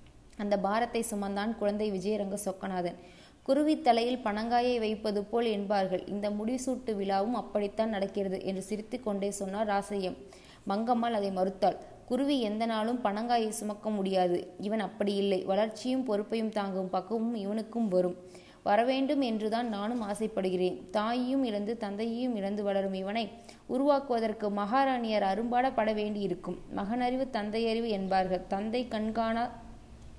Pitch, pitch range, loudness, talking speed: 215 Hz, 200-230 Hz, -31 LUFS, 115 wpm